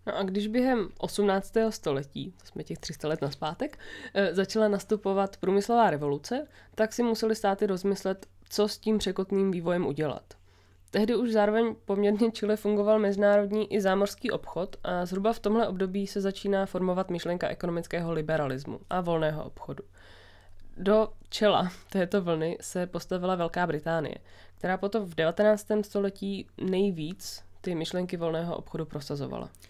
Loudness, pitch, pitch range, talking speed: -29 LUFS, 190 Hz, 165-210 Hz, 140 wpm